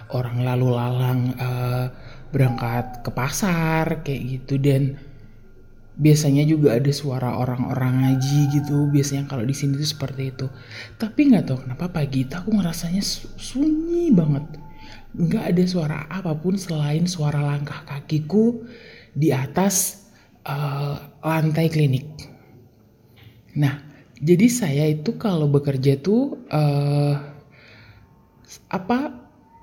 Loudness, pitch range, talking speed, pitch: -22 LUFS, 130-165 Hz, 110 wpm, 145 Hz